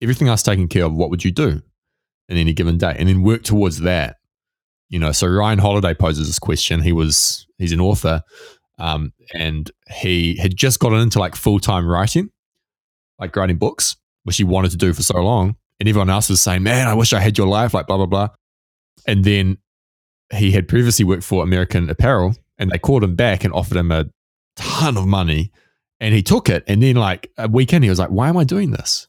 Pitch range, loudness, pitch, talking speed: 85-110 Hz, -17 LUFS, 95 Hz, 220 wpm